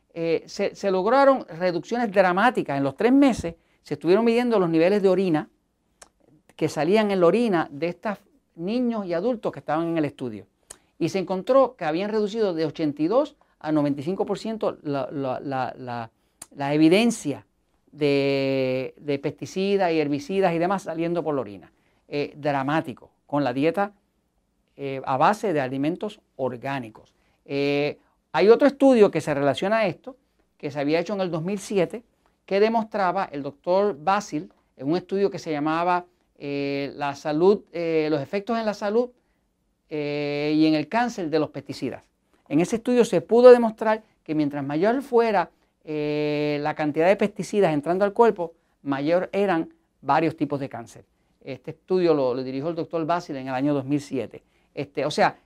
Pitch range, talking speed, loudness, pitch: 145-200 Hz, 165 wpm, -23 LUFS, 165 Hz